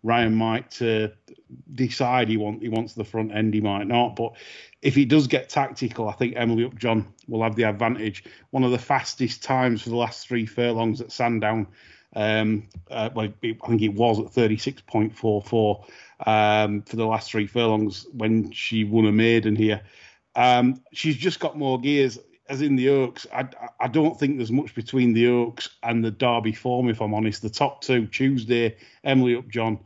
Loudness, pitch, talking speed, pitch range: -23 LUFS, 115 Hz, 185 wpm, 110-125 Hz